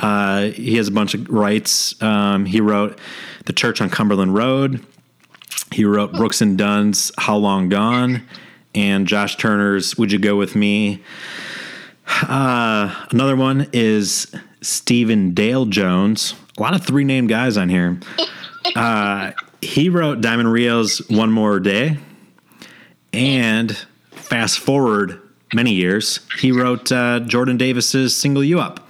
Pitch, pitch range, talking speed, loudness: 110 Hz, 105-125 Hz, 140 wpm, -17 LUFS